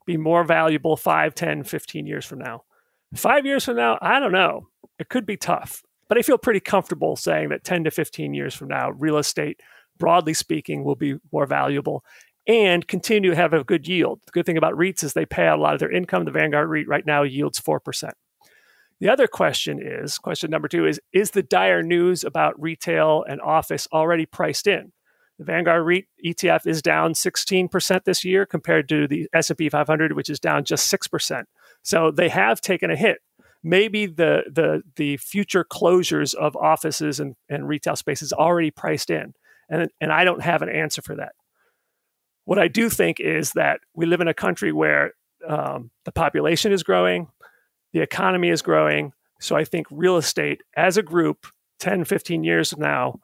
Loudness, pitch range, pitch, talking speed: -21 LUFS, 150-180 Hz, 165 Hz, 195 wpm